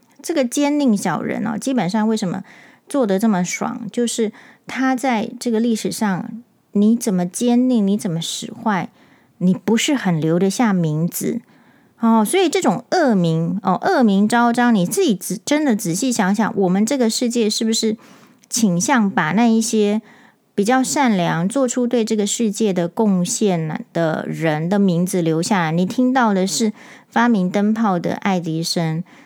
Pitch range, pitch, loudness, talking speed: 190-245 Hz, 220 Hz, -18 LUFS, 240 characters per minute